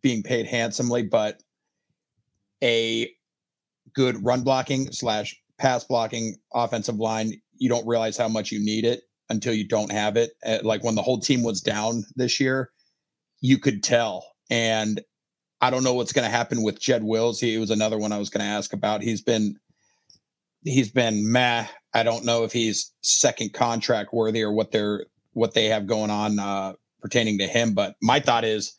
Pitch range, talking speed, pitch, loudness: 110-120 Hz, 185 wpm, 115 Hz, -24 LUFS